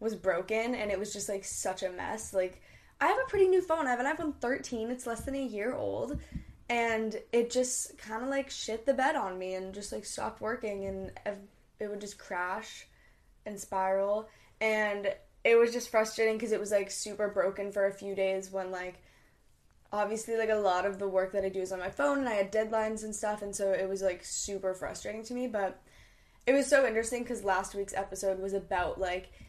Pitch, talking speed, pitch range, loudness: 210 Hz, 220 wpm, 195-235 Hz, -32 LUFS